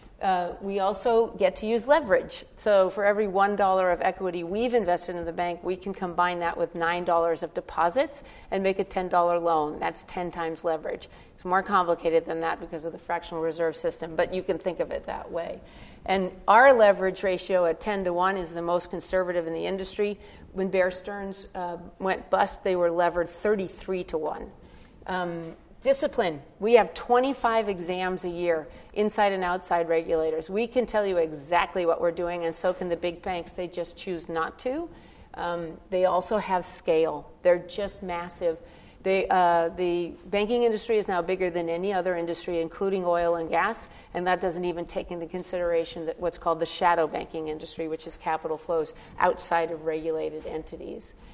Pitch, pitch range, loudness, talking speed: 180 Hz, 170-195 Hz, -27 LUFS, 185 wpm